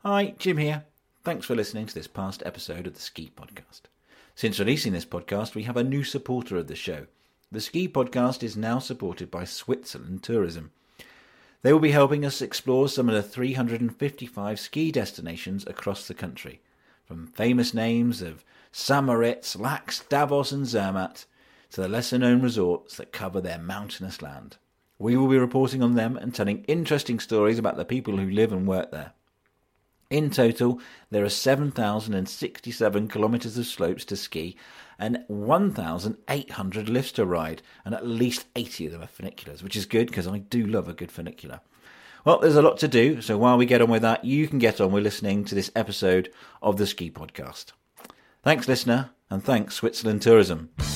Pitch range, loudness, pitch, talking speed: 100-130 Hz, -25 LUFS, 115 Hz, 180 wpm